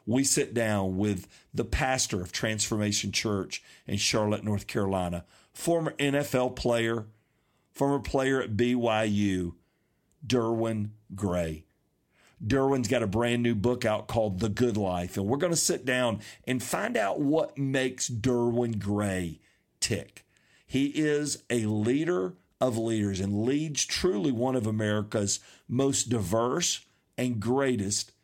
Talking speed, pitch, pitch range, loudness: 135 wpm, 115 Hz, 105-130 Hz, -28 LUFS